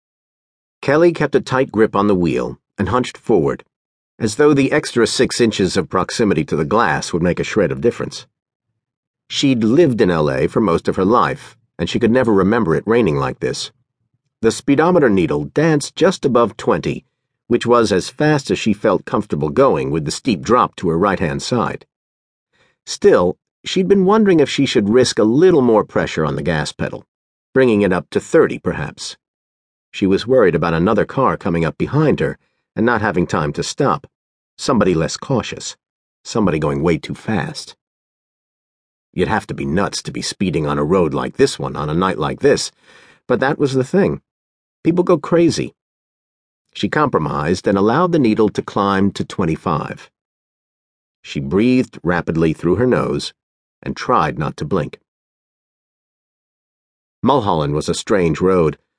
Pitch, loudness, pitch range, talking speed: 120 Hz, -17 LUFS, 85-145 Hz, 175 wpm